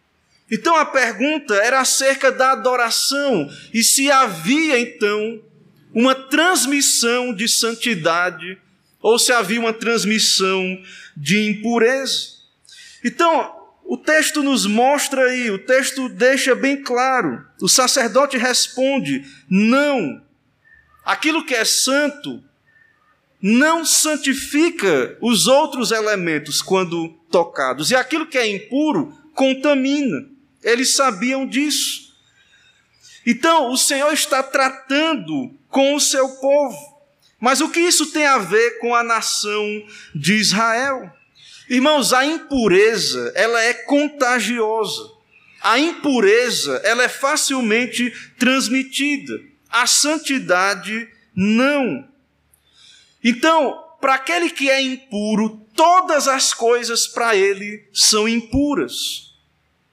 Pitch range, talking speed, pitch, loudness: 225-285 Hz, 105 wpm, 260 Hz, -17 LUFS